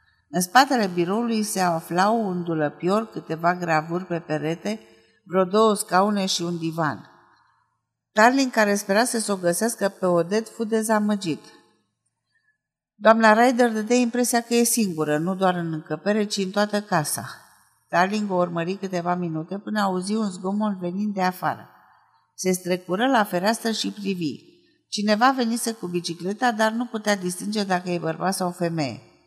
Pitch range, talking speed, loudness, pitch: 175-220 Hz, 155 wpm, -23 LUFS, 195 Hz